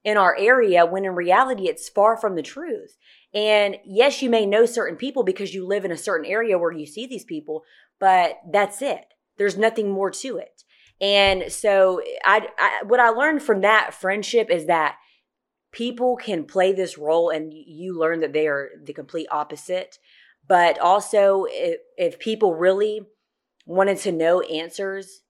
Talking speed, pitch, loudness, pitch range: 175 wpm, 195 Hz, -21 LUFS, 175-225 Hz